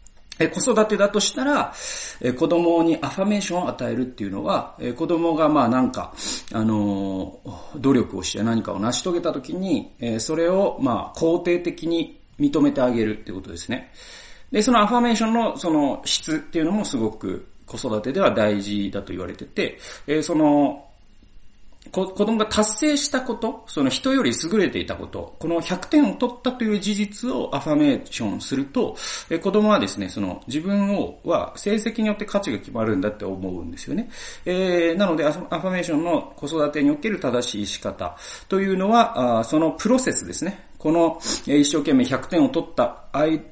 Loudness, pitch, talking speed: -22 LUFS, 175 Hz, 350 characters per minute